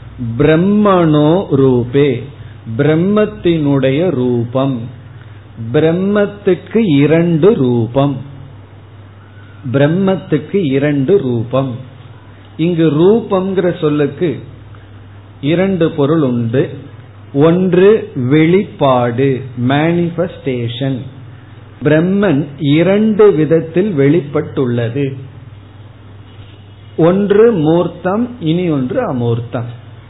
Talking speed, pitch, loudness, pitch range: 55 wpm, 140 Hz, -13 LUFS, 120-170 Hz